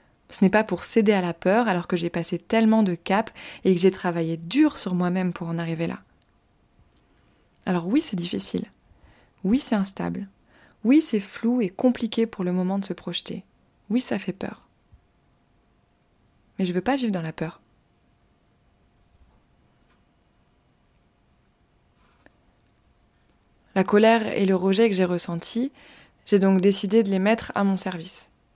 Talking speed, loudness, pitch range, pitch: 155 wpm, -24 LUFS, 180-225 Hz, 195 Hz